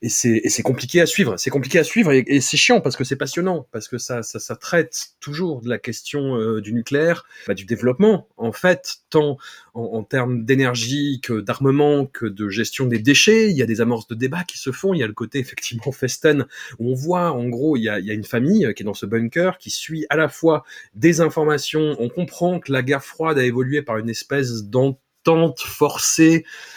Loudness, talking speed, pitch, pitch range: -19 LUFS, 235 wpm, 135 Hz, 120-160 Hz